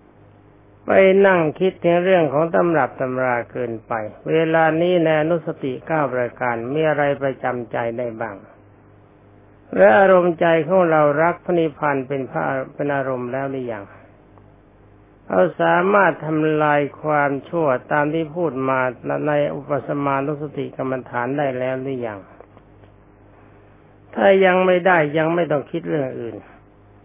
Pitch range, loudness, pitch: 110-160 Hz, -19 LUFS, 135 Hz